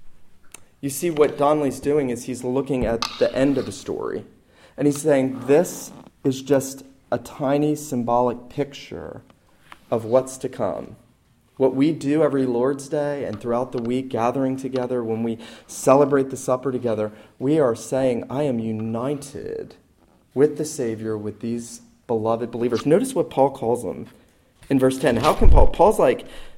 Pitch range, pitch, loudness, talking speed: 120-140 Hz, 130 Hz, -22 LUFS, 165 wpm